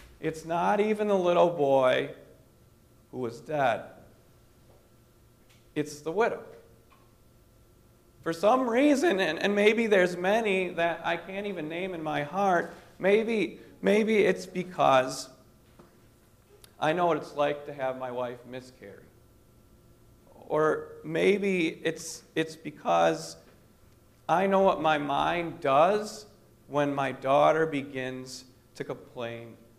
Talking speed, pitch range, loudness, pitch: 120 wpm, 120-180 Hz, -27 LUFS, 145 Hz